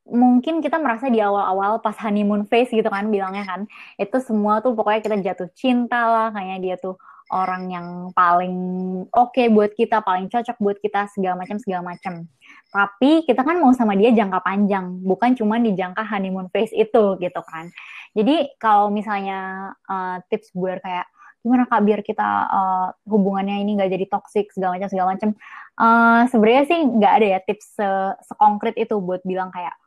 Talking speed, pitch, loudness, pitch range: 180 wpm, 205 Hz, -20 LUFS, 185-230 Hz